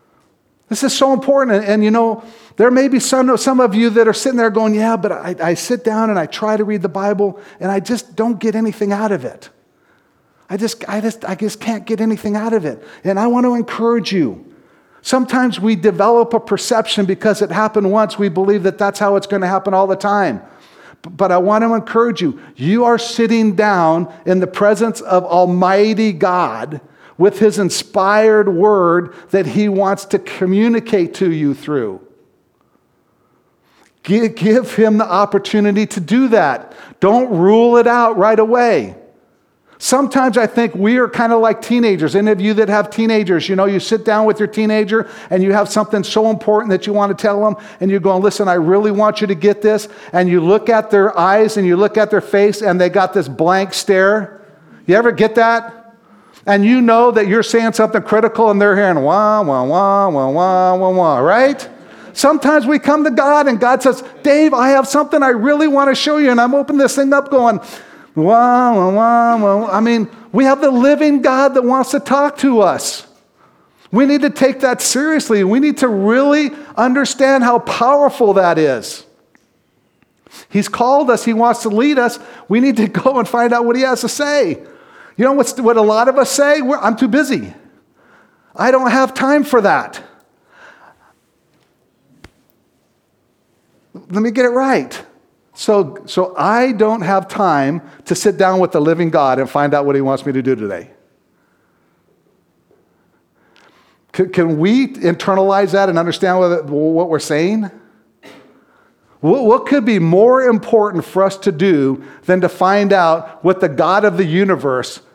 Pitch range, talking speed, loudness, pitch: 195-240 Hz, 190 wpm, -13 LUFS, 215 Hz